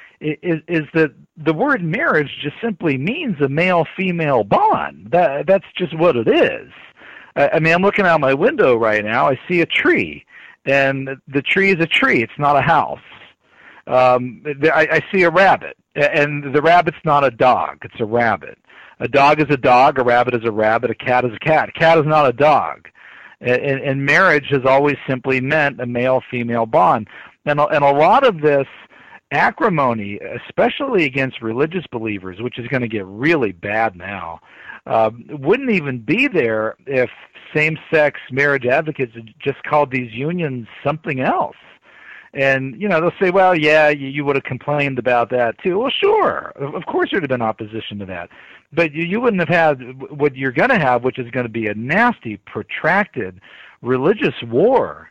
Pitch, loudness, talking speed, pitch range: 140 Hz, -17 LUFS, 185 wpm, 125-160 Hz